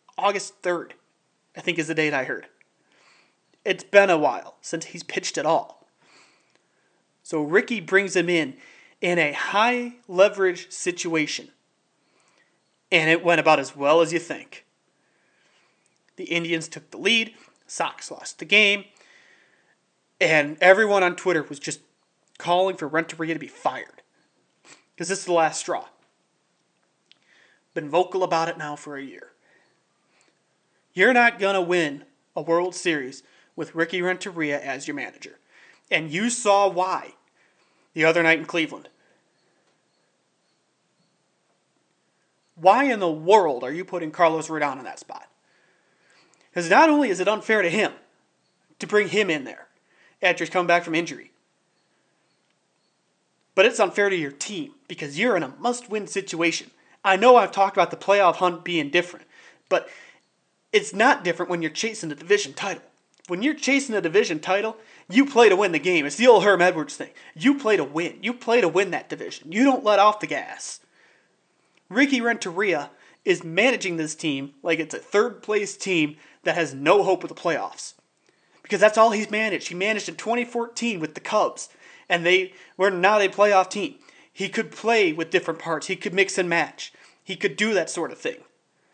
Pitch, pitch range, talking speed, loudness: 185 Hz, 165-210 Hz, 165 wpm, -22 LUFS